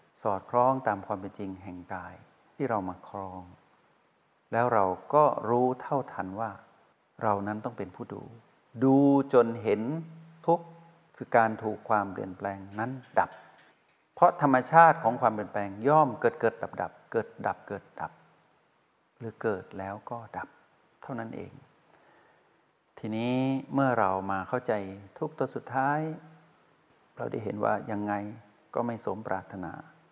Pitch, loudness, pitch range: 115 Hz, -29 LUFS, 100-140 Hz